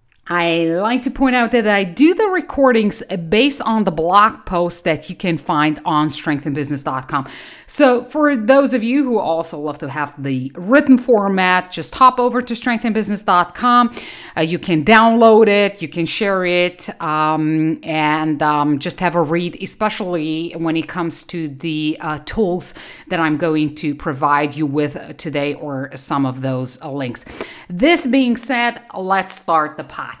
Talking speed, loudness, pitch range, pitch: 165 wpm, -16 LUFS, 155-225 Hz, 175 Hz